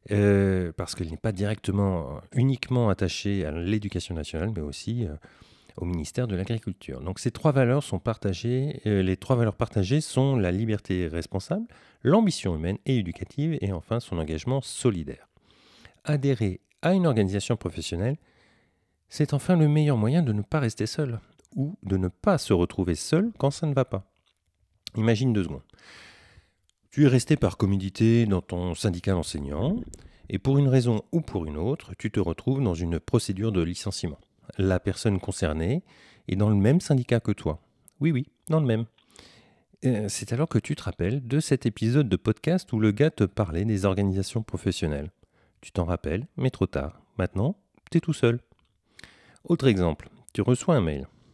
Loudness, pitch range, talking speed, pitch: -26 LUFS, 95-130 Hz, 175 wpm, 105 Hz